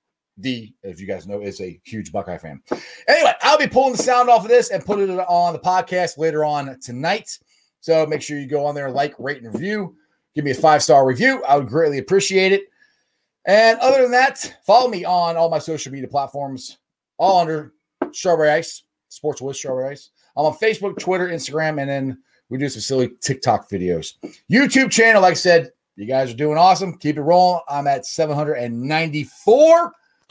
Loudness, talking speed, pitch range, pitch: -18 LUFS, 195 wpm, 135-190 Hz, 155 Hz